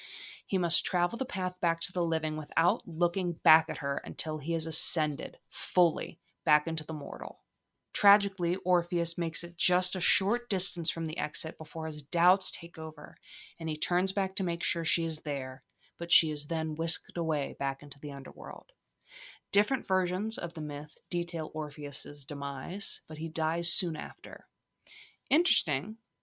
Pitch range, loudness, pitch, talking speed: 155-180 Hz, -29 LUFS, 165 Hz, 165 wpm